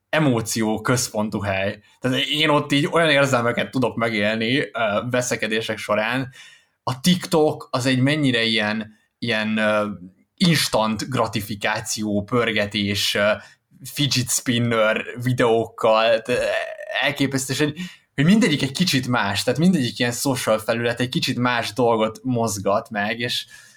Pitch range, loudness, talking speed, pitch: 110-140 Hz, -21 LUFS, 110 wpm, 120 Hz